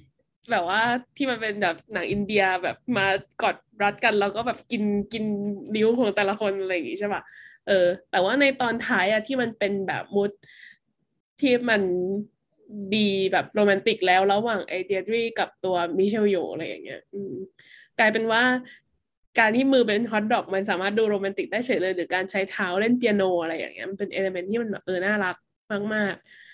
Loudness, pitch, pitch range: -24 LUFS, 205 Hz, 190-225 Hz